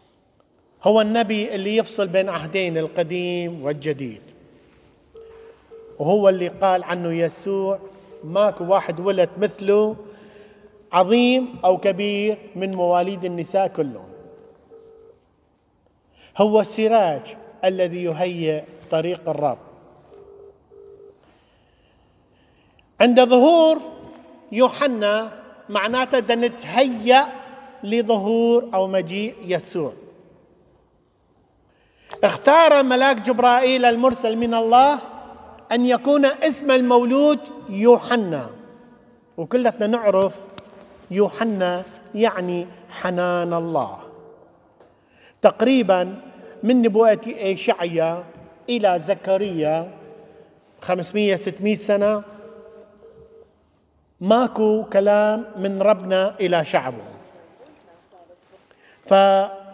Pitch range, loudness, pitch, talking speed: 185-245 Hz, -19 LUFS, 210 Hz, 70 wpm